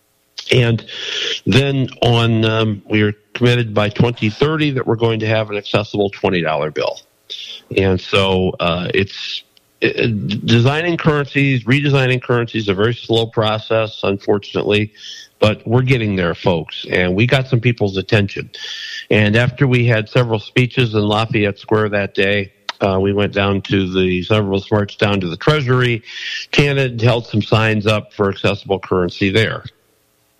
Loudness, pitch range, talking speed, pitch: -16 LUFS, 100-125 Hz, 150 wpm, 110 Hz